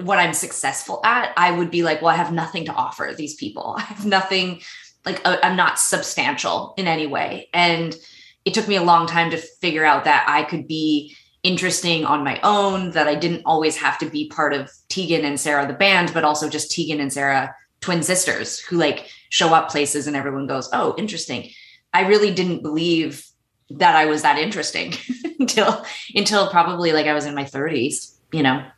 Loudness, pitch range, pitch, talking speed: -19 LUFS, 150-185 Hz, 165 Hz, 200 wpm